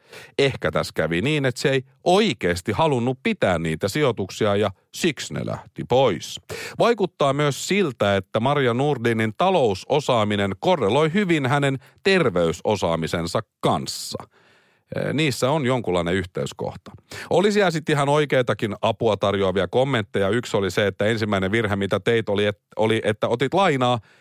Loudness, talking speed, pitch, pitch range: -22 LUFS, 130 wpm, 125 Hz, 100-150 Hz